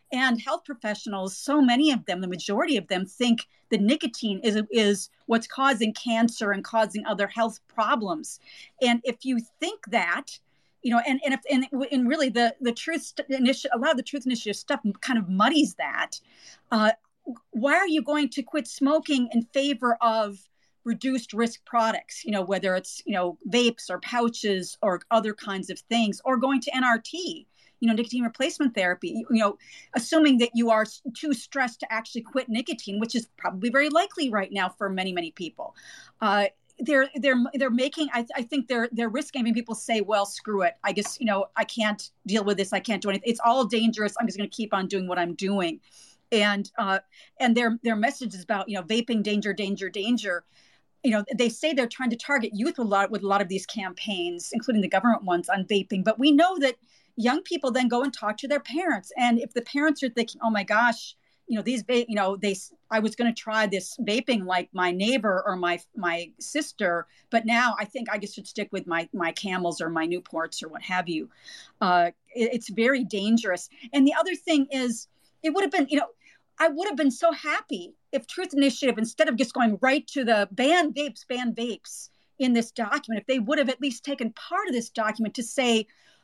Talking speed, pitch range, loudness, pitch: 215 wpm, 205-270 Hz, -26 LUFS, 235 Hz